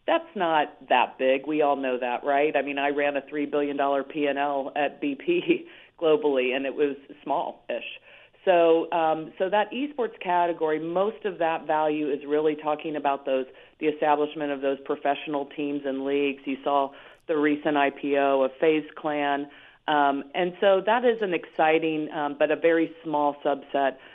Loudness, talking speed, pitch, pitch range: -25 LUFS, 170 wpm, 150 Hz, 140-165 Hz